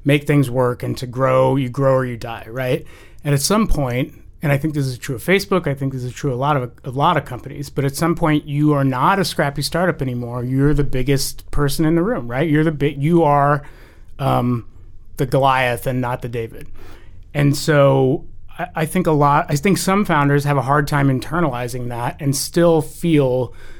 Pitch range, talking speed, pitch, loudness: 125-150 Hz, 220 wpm, 140 Hz, -18 LUFS